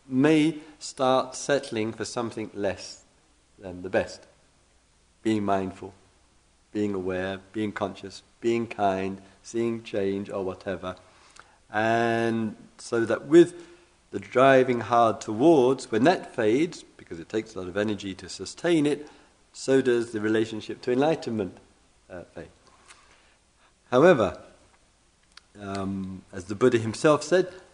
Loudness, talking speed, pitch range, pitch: -25 LUFS, 125 wpm, 95-125 Hz, 105 Hz